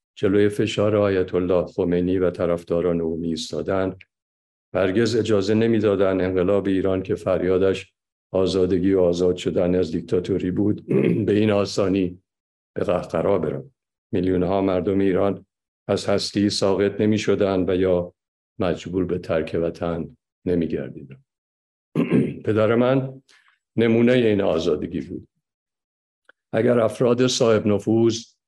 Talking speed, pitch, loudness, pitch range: 115 wpm, 95 Hz, -21 LUFS, 90-105 Hz